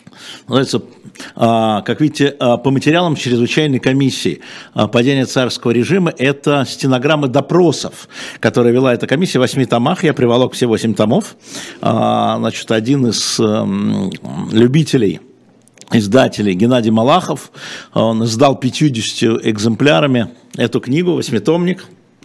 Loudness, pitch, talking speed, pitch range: -14 LUFS, 130 Hz, 105 wpm, 115-150 Hz